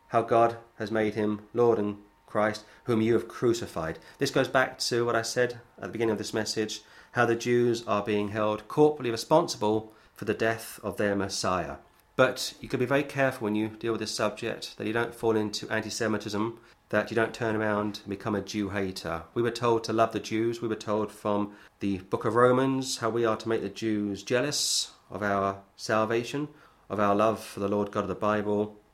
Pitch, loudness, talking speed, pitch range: 110 Hz, -28 LUFS, 215 wpm, 105-120 Hz